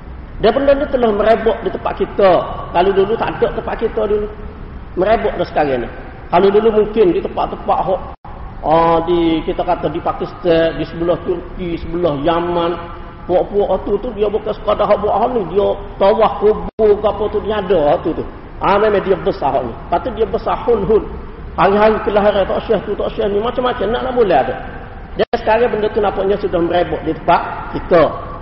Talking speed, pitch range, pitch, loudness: 185 wpm, 175-220 Hz, 205 Hz, -16 LUFS